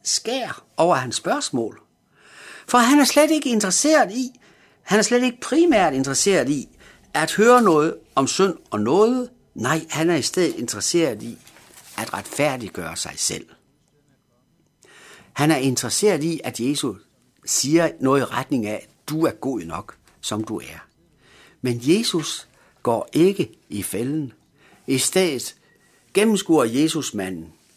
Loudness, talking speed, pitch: -20 LUFS, 145 wpm, 165 Hz